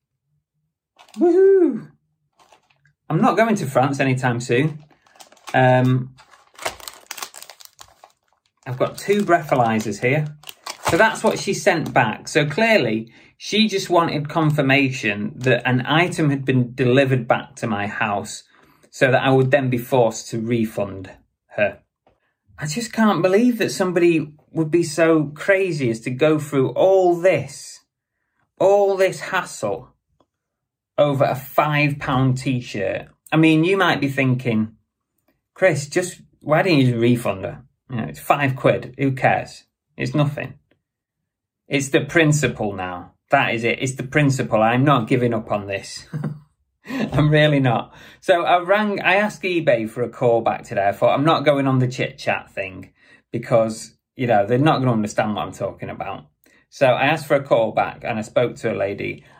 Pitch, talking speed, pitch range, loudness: 140 Hz, 160 wpm, 125-165 Hz, -19 LUFS